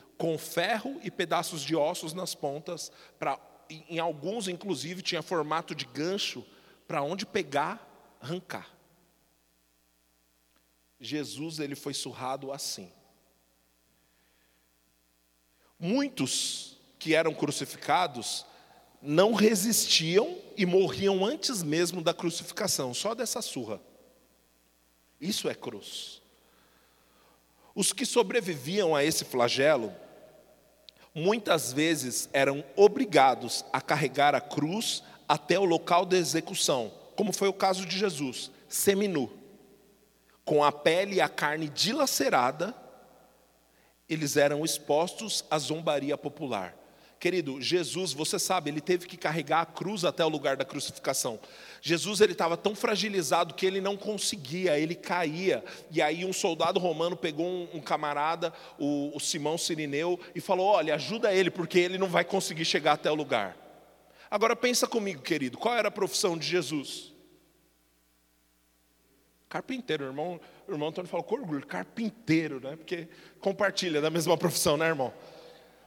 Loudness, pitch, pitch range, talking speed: -29 LUFS, 165 Hz, 145-190 Hz, 125 wpm